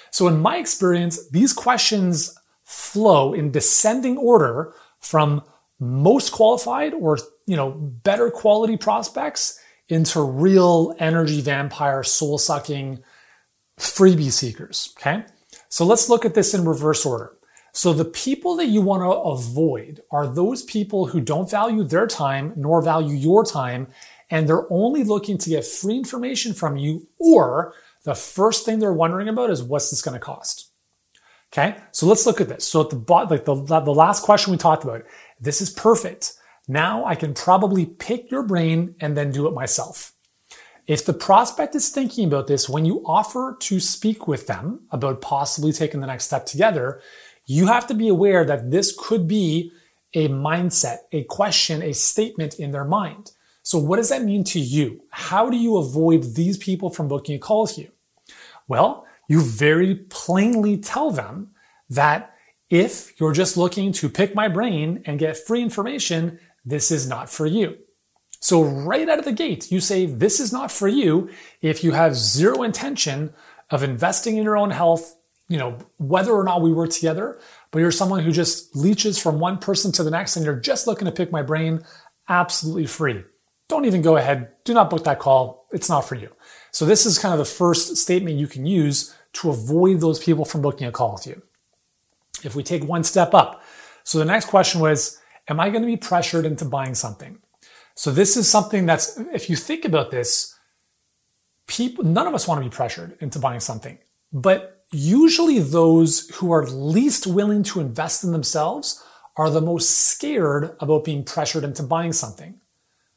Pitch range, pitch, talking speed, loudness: 150-205 Hz, 170 Hz, 180 wpm, -19 LUFS